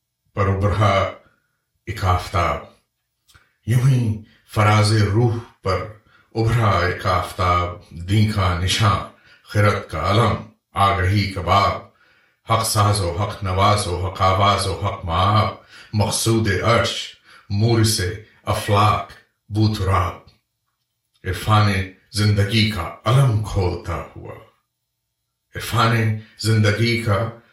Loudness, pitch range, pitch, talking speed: -19 LUFS, 95-110 Hz, 105 Hz, 80 wpm